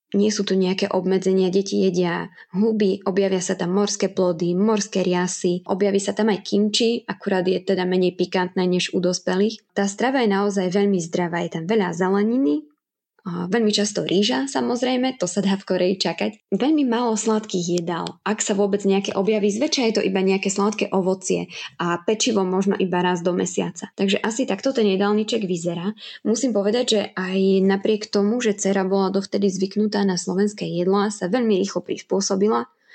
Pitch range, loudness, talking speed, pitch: 185-215 Hz, -21 LUFS, 175 wpm, 195 Hz